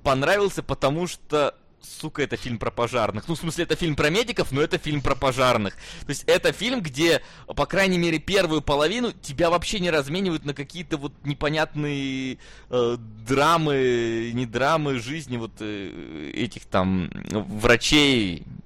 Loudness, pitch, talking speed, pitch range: -24 LUFS, 145 Hz, 155 wpm, 125-165 Hz